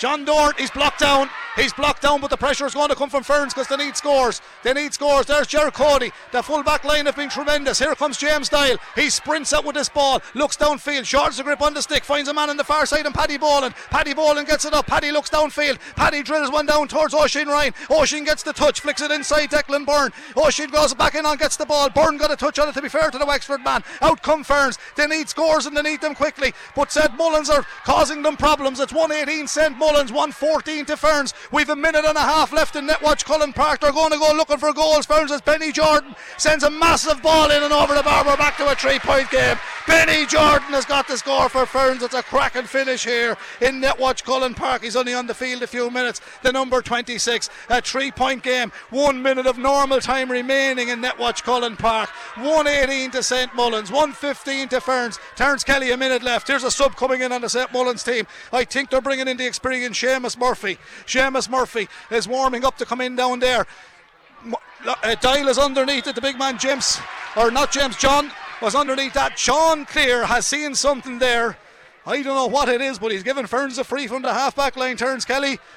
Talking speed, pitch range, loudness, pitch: 230 wpm, 255-295 Hz, -19 LUFS, 280 Hz